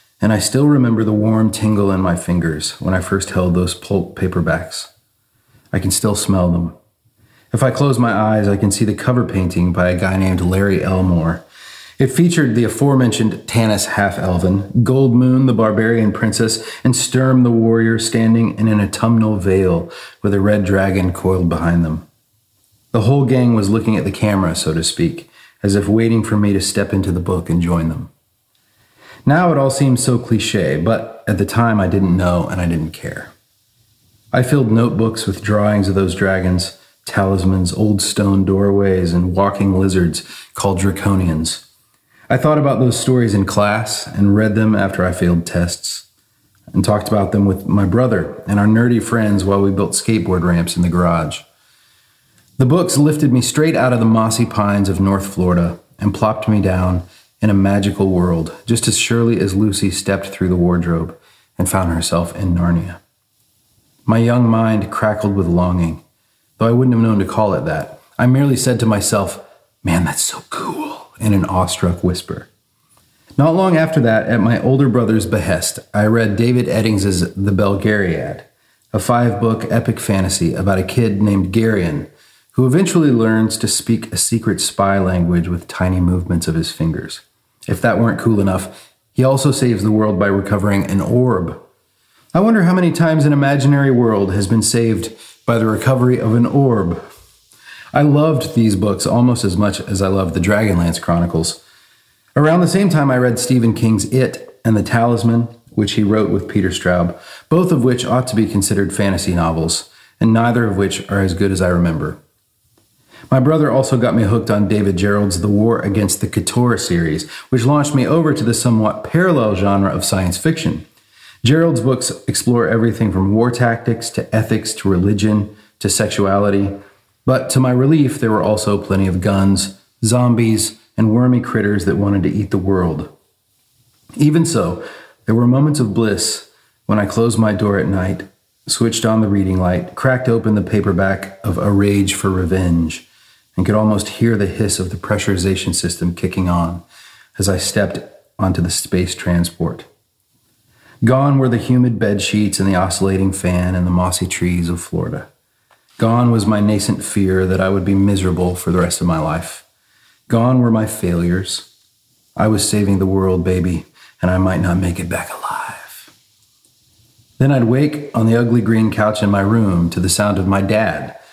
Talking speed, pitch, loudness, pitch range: 180 wpm, 105 Hz, -15 LUFS, 95-115 Hz